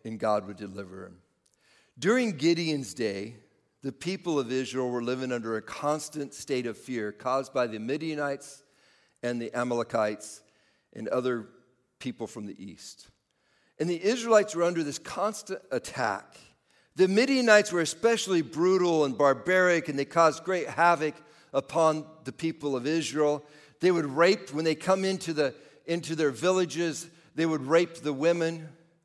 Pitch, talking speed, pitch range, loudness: 150 Hz, 155 wpm, 125-170 Hz, -28 LUFS